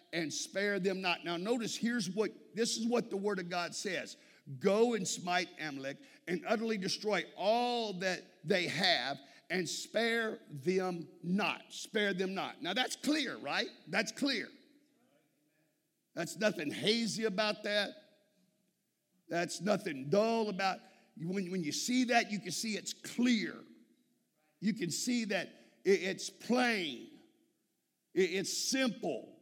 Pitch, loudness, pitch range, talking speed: 205 Hz, -35 LUFS, 180-230 Hz, 135 wpm